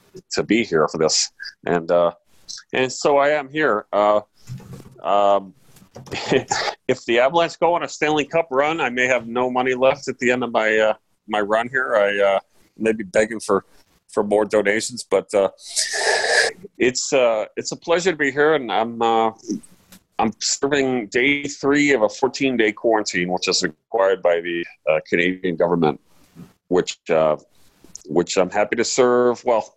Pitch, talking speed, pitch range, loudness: 115 Hz, 170 wpm, 100-140 Hz, -20 LUFS